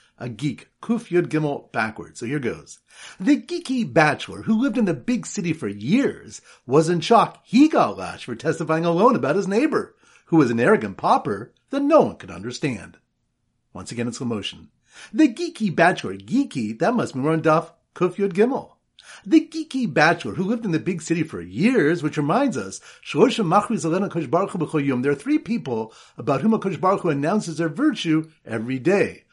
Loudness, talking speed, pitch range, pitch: -22 LUFS, 175 wpm, 155-235 Hz, 175 Hz